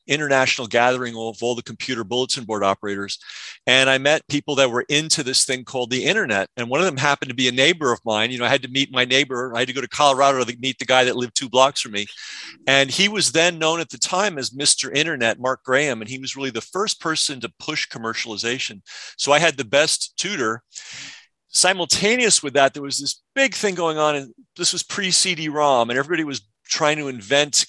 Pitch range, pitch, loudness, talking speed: 125-150 Hz, 135 Hz, -19 LUFS, 230 wpm